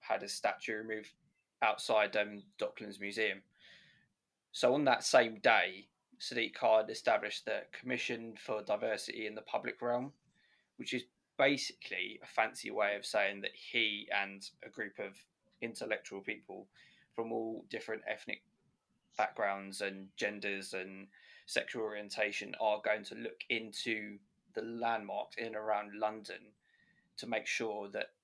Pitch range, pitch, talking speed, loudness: 100-115 Hz, 105 Hz, 140 wpm, -36 LUFS